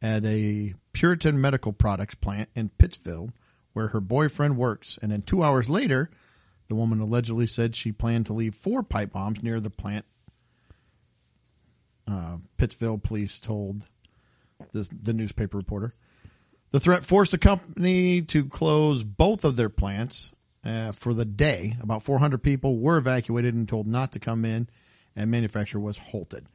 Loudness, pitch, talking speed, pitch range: -26 LUFS, 115 Hz, 155 wpm, 105-130 Hz